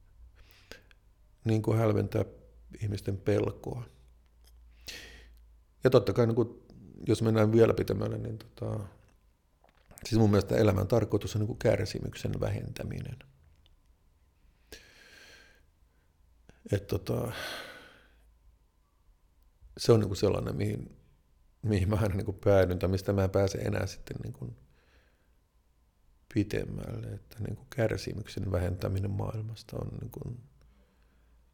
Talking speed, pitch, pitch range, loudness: 105 wpm, 100 Hz, 75-110 Hz, -31 LUFS